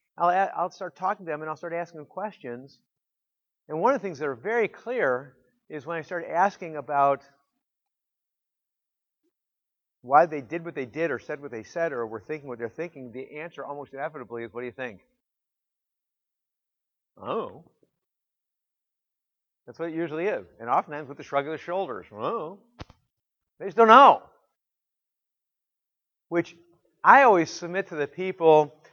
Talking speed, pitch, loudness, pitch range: 165 wpm, 155 Hz, -24 LUFS, 140-175 Hz